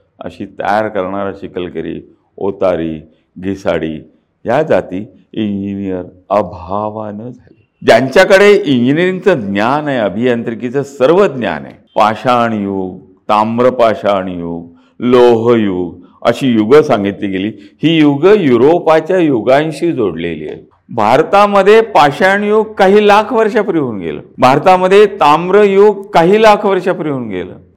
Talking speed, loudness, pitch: 110 wpm, -11 LUFS, 125 Hz